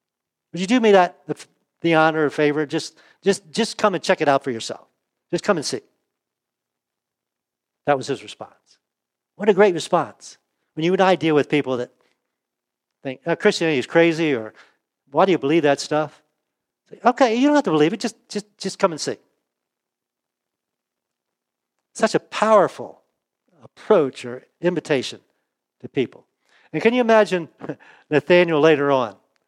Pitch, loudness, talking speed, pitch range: 160 Hz, -20 LUFS, 165 wpm, 140-190 Hz